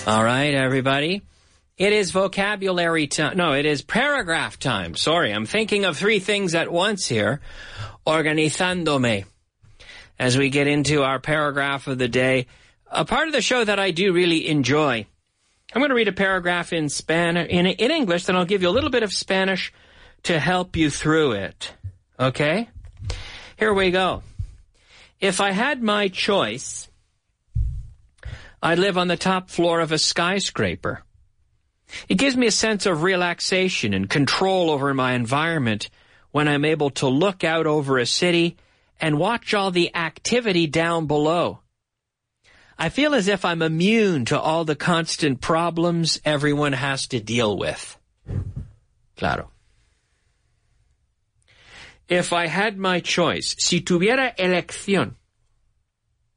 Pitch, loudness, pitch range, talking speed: 160 Hz, -21 LUFS, 130-185 Hz, 145 wpm